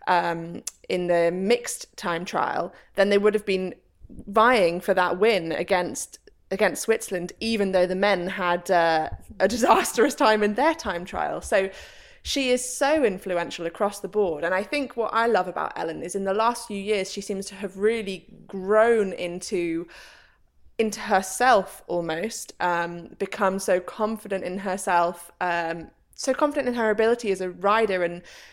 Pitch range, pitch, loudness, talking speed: 180-220 Hz, 195 Hz, -24 LUFS, 165 wpm